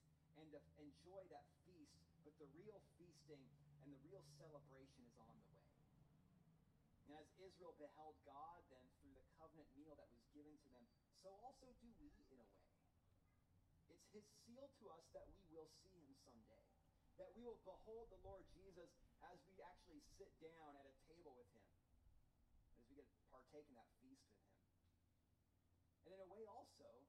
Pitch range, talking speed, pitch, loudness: 115-170 Hz, 175 wpm, 145 Hz, -66 LUFS